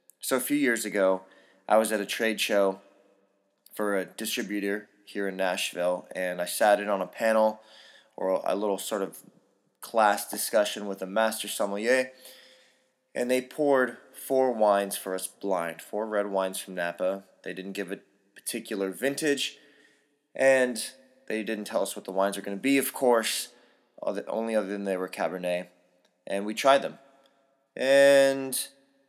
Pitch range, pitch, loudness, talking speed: 95-130 Hz, 105 Hz, -27 LUFS, 165 wpm